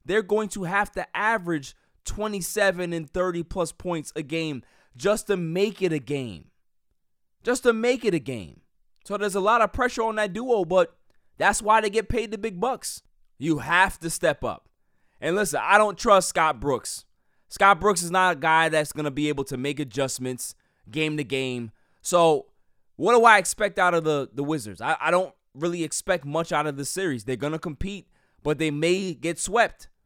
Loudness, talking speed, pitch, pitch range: -24 LUFS, 200 wpm, 170 Hz, 145-205 Hz